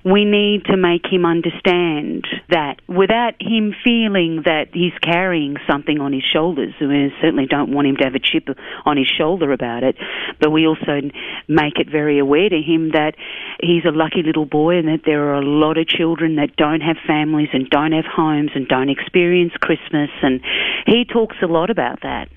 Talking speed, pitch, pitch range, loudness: 195 wpm, 160 Hz, 145-175 Hz, -17 LUFS